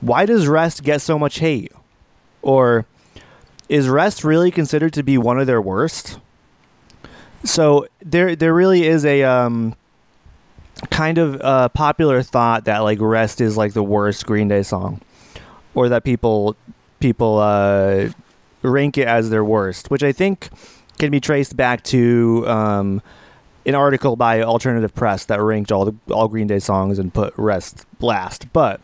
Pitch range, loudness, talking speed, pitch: 110-145 Hz, -17 LUFS, 160 wpm, 125 Hz